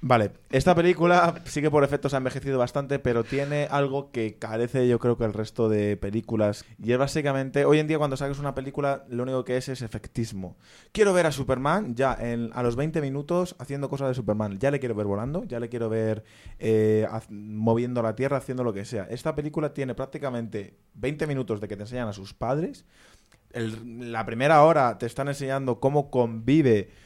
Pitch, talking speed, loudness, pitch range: 125 Hz, 205 wpm, -26 LUFS, 115-140 Hz